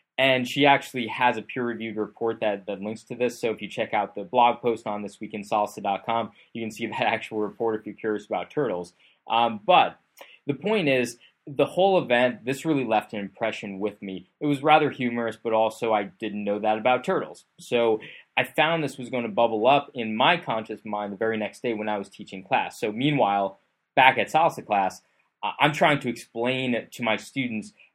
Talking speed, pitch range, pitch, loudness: 205 wpm, 105-125 Hz, 115 Hz, -25 LUFS